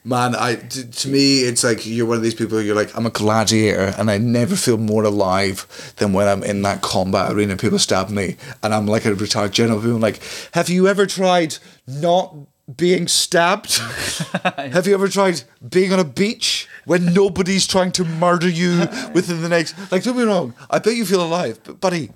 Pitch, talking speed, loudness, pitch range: 140 Hz, 210 wpm, -18 LUFS, 110-180 Hz